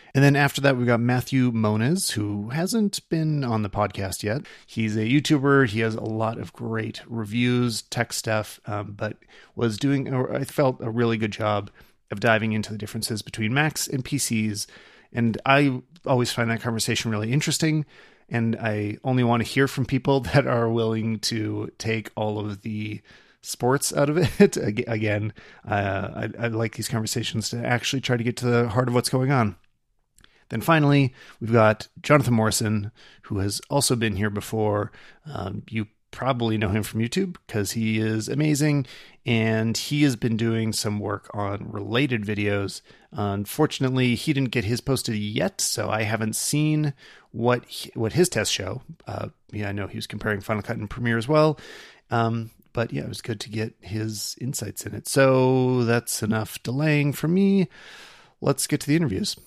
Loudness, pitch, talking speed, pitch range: -24 LUFS, 115 Hz, 185 wpm, 110-135 Hz